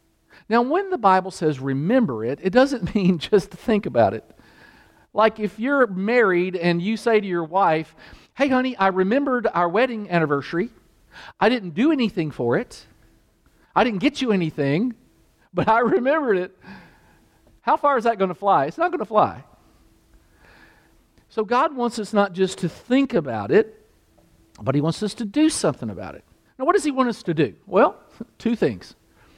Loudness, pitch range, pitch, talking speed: -21 LUFS, 185-255 Hz, 220 Hz, 180 wpm